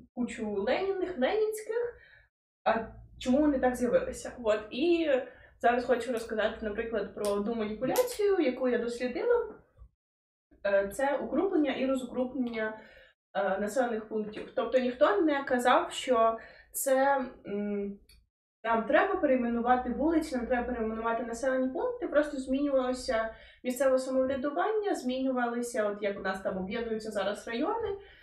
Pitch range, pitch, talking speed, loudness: 225-285 Hz, 255 Hz, 115 wpm, -30 LUFS